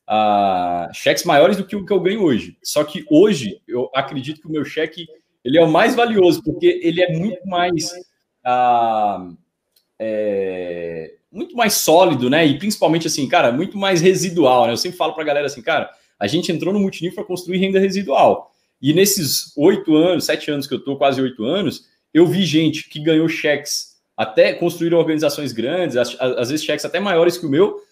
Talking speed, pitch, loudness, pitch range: 190 wpm, 165 Hz, -17 LUFS, 140-185 Hz